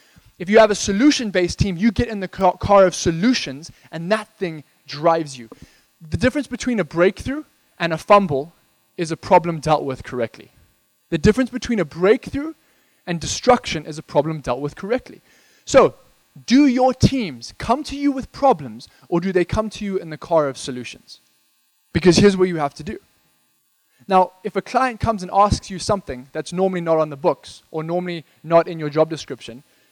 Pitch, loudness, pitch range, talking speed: 180 Hz, -19 LUFS, 155-215 Hz, 190 wpm